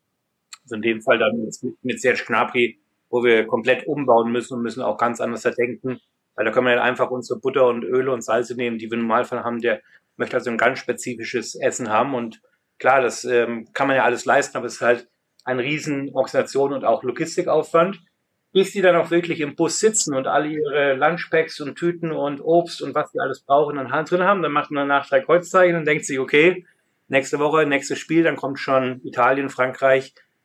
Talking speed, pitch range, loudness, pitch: 210 wpm, 125-155 Hz, -20 LUFS, 140 Hz